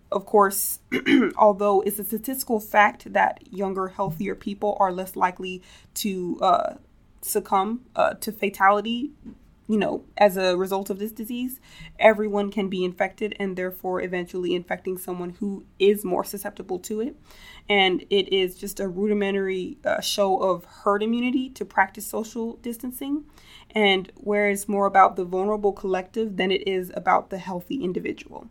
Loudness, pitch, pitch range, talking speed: -24 LUFS, 200 Hz, 190-215 Hz, 155 wpm